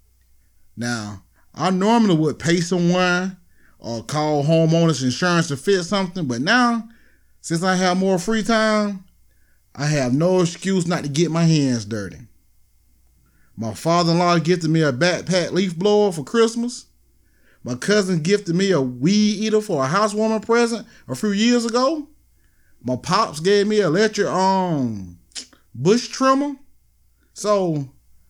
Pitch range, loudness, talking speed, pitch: 130-205 Hz, -19 LUFS, 140 wpm, 175 Hz